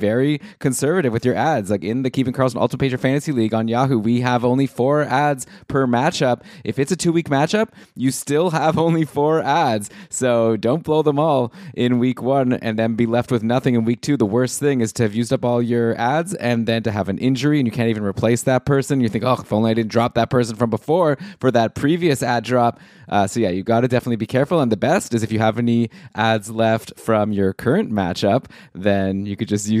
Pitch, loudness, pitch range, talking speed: 120 Hz, -19 LUFS, 115-140 Hz, 245 wpm